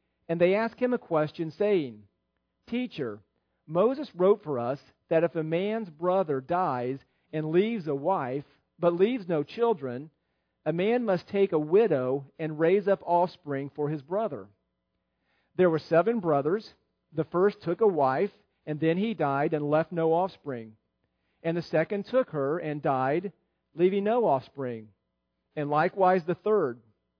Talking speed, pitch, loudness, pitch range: 155 wpm, 160 Hz, -28 LUFS, 140-190 Hz